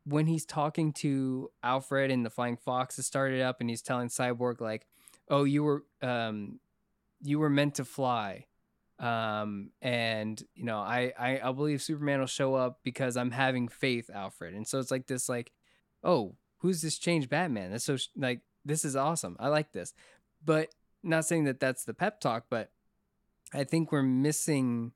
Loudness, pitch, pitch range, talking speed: -32 LUFS, 130 Hz, 120-145 Hz, 185 wpm